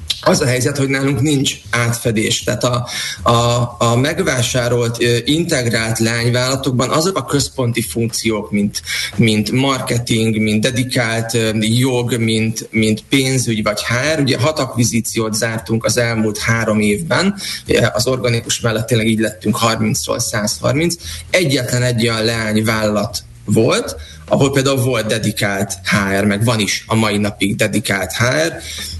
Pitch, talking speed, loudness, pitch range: 115 Hz, 130 wpm, -16 LUFS, 110-125 Hz